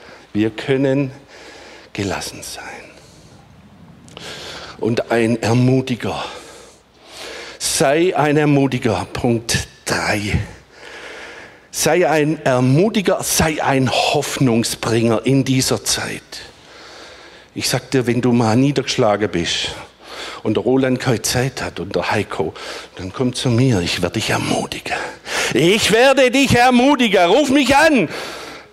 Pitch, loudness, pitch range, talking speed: 130 Hz, -17 LUFS, 115-140 Hz, 110 wpm